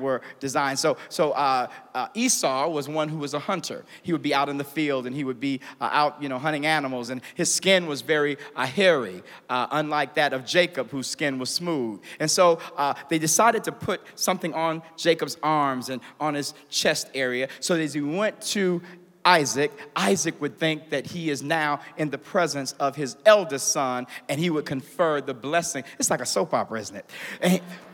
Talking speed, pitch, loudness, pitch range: 210 wpm, 150 Hz, -25 LUFS, 140-170 Hz